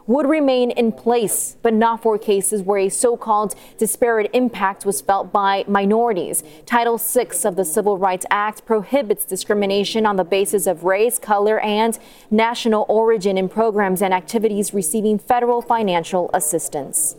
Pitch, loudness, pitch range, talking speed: 215 Hz, -18 LUFS, 195-230 Hz, 155 wpm